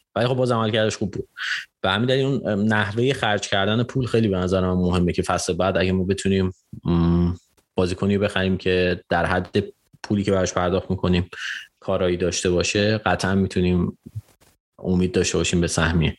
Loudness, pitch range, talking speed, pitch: -22 LUFS, 90-105 Hz, 175 wpm, 95 Hz